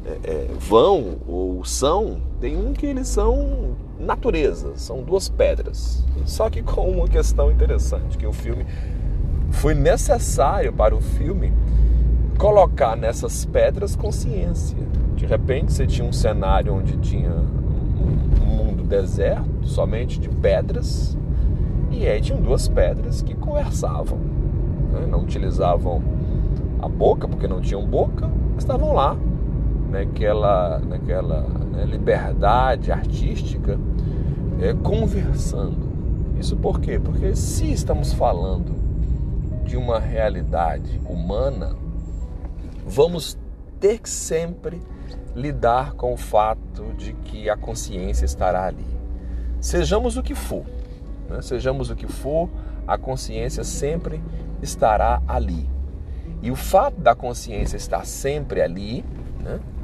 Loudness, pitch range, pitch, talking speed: -22 LUFS, 65-100 Hz, 80 Hz, 120 wpm